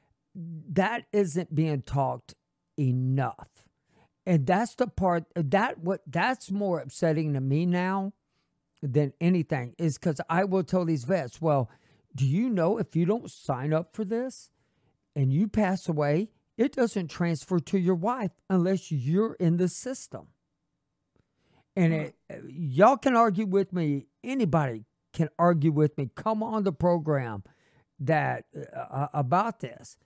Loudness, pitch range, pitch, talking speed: -27 LUFS, 150-195 Hz, 170 Hz, 145 wpm